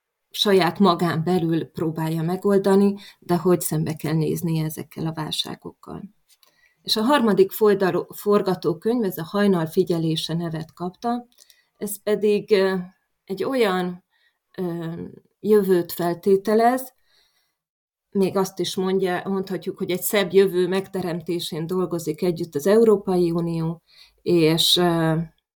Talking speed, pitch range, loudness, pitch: 105 wpm, 170-200 Hz, -22 LUFS, 185 Hz